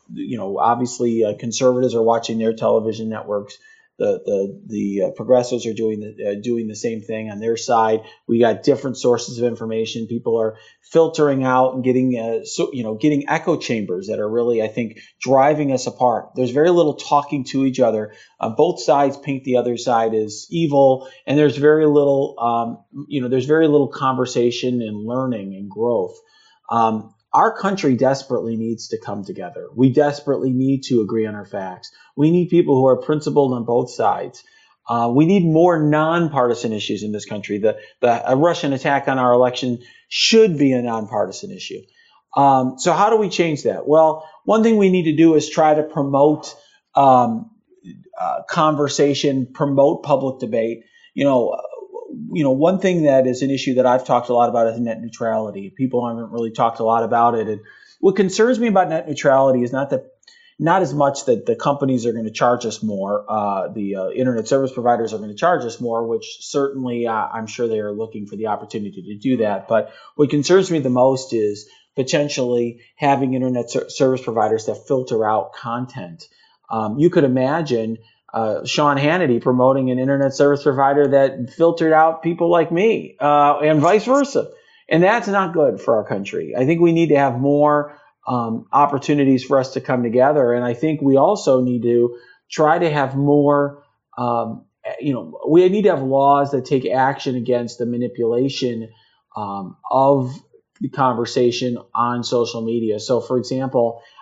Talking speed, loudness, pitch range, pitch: 190 wpm, -18 LUFS, 115-150 Hz, 130 Hz